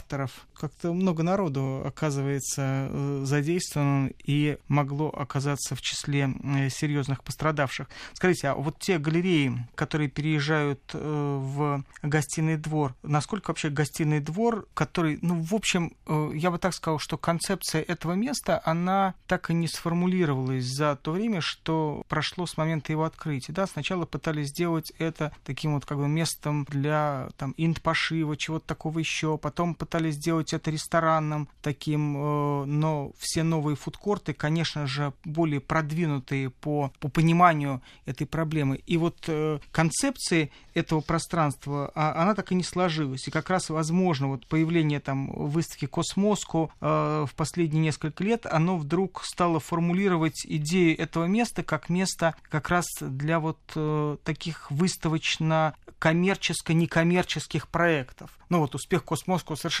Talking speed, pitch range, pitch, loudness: 130 wpm, 145-170 Hz, 155 Hz, -27 LUFS